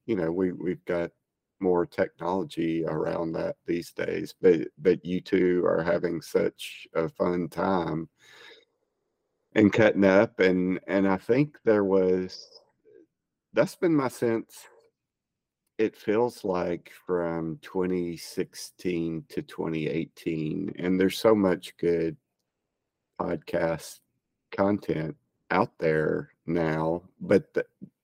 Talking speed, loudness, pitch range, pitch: 115 wpm, -27 LUFS, 85-110 Hz, 90 Hz